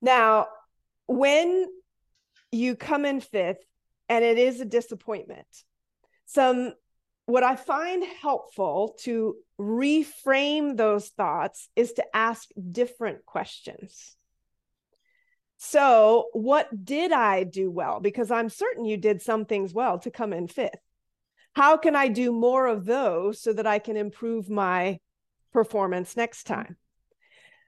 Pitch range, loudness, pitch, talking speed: 215-285 Hz, -25 LUFS, 235 Hz, 130 wpm